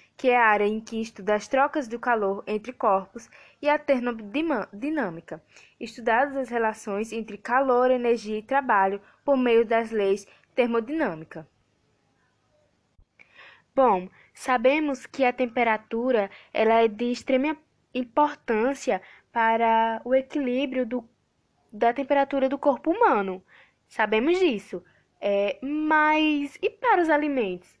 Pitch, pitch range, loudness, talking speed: 245 Hz, 215-275 Hz, -25 LUFS, 120 wpm